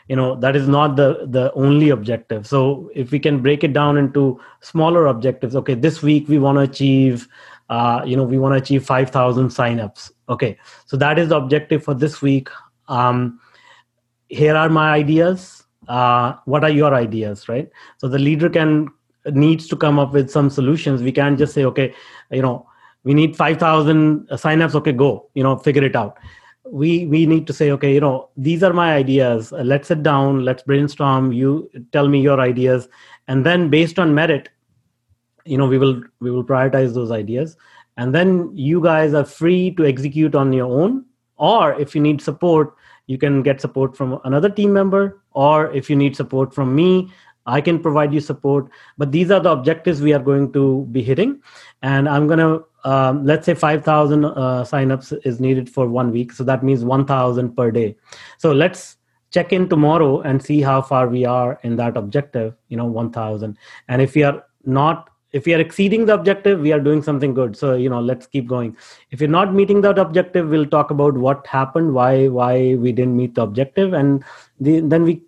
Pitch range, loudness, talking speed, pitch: 130-155 Hz, -17 LUFS, 200 wpm, 140 Hz